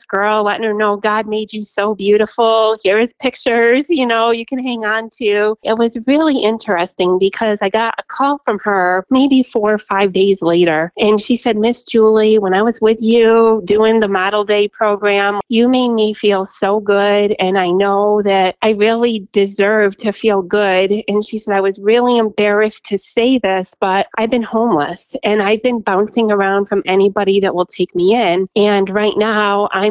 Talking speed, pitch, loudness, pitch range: 195 wpm, 210 Hz, -14 LUFS, 200-225 Hz